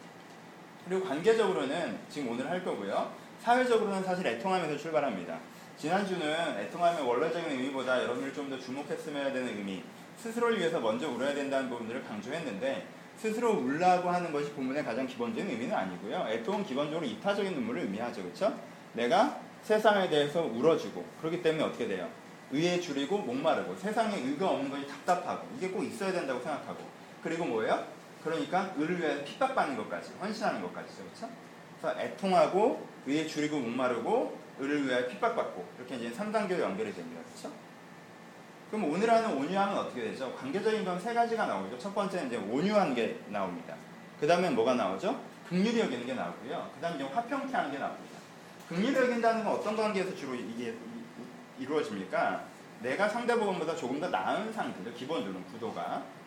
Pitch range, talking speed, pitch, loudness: 150-220 Hz, 420 characters per minute, 180 Hz, -32 LUFS